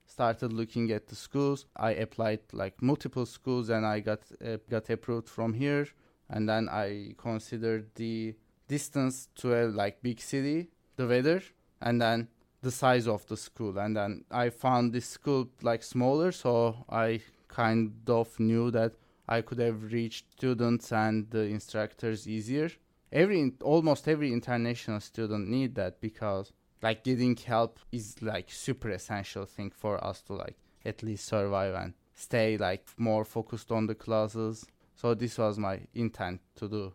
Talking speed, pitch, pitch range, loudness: 160 wpm, 115 Hz, 110-125 Hz, -32 LUFS